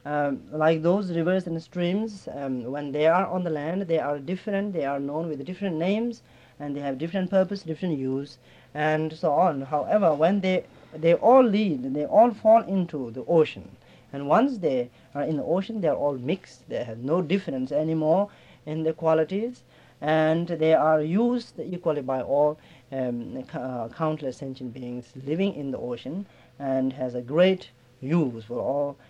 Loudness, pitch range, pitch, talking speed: -25 LUFS, 135-185 Hz, 155 Hz, 175 wpm